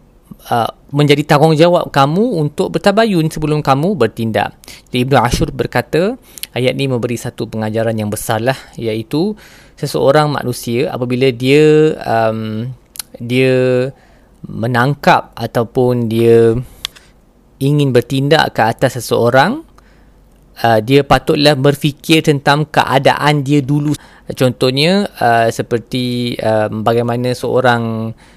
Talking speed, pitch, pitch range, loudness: 100 wpm, 130 Hz, 115-150 Hz, -14 LUFS